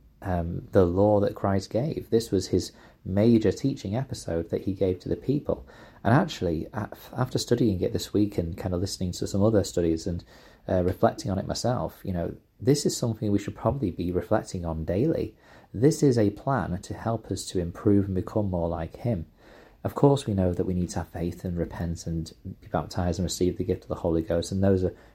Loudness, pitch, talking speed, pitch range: -27 LUFS, 95 Hz, 215 wpm, 90-110 Hz